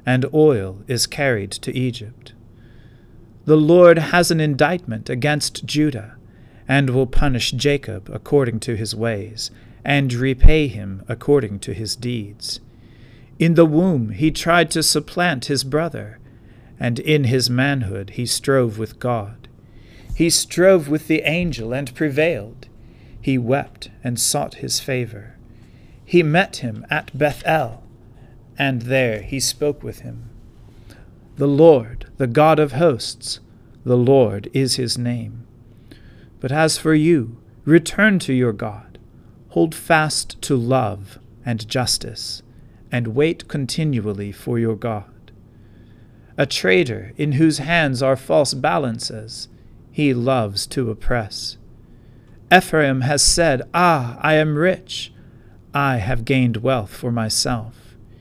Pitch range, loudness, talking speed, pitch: 115-145 Hz, -18 LUFS, 130 wpm, 125 Hz